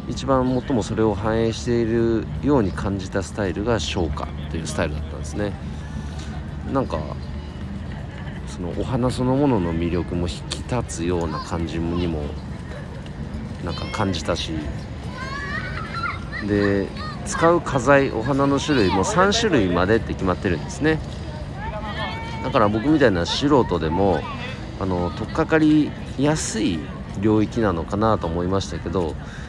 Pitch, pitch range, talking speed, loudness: 95 Hz, 80-115 Hz, 280 characters per minute, -23 LUFS